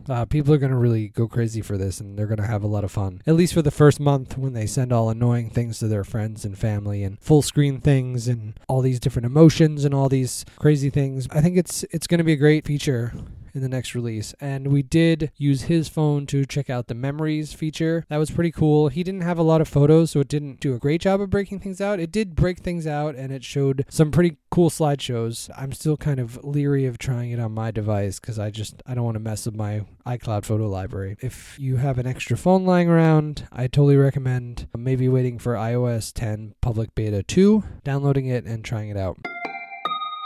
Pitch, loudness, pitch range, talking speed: 135 Hz, -22 LUFS, 115-150 Hz, 235 wpm